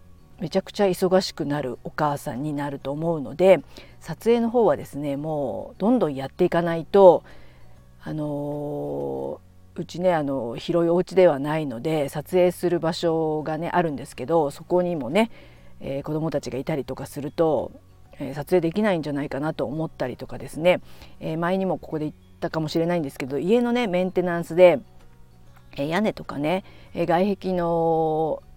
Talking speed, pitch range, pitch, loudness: 340 characters per minute, 140-180 Hz, 160 Hz, -23 LUFS